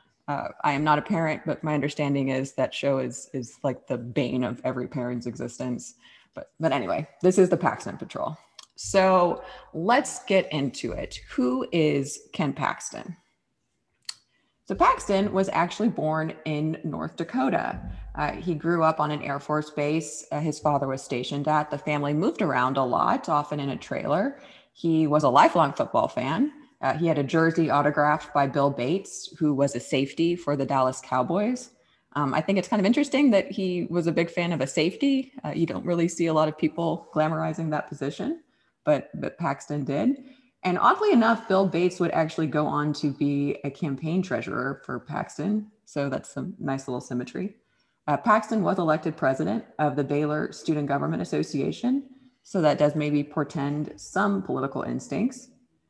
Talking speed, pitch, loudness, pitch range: 180 wpm, 155 Hz, -26 LUFS, 145-190 Hz